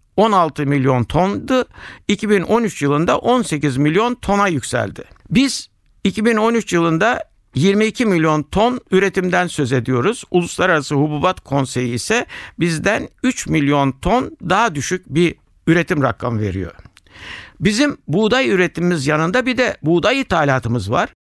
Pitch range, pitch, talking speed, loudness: 140-205 Hz, 170 Hz, 115 wpm, -17 LUFS